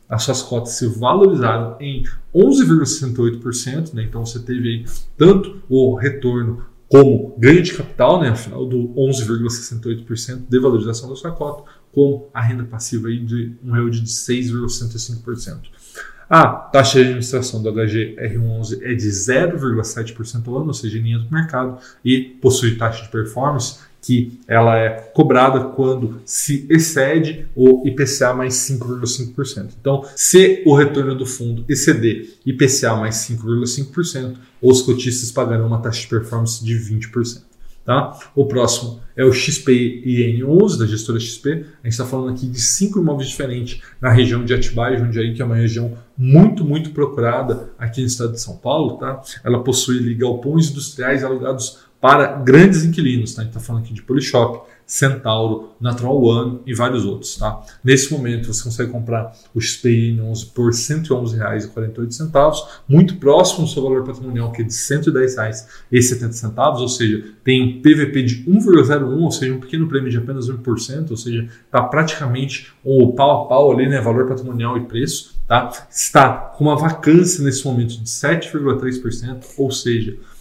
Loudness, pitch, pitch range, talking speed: -17 LUFS, 125 Hz, 115-135 Hz, 155 wpm